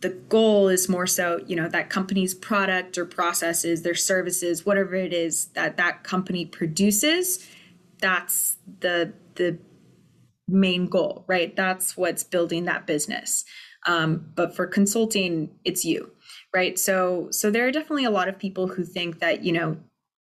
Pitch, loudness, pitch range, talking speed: 180 Hz, -24 LUFS, 175-195 Hz, 155 wpm